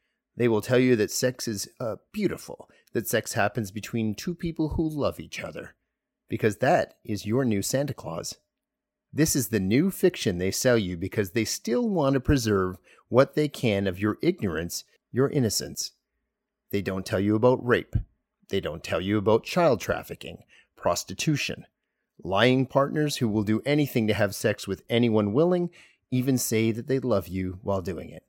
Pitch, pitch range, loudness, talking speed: 115 Hz, 105-140 Hz, -26 LUFS, 175 wpm